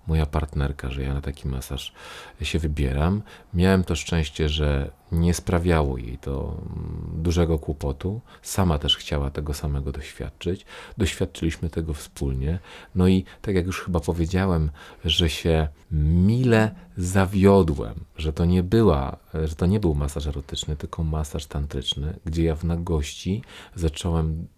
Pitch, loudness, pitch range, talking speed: 80 Hz, -25 LUFS, 75-90 Hz, 140 wpm